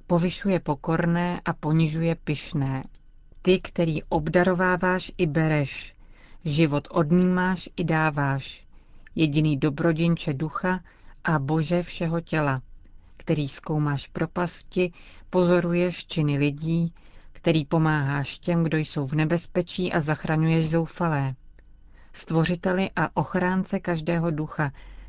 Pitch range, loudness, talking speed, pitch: 150-175 Hz, -25 LUFS, 100 wpm, 165 Hz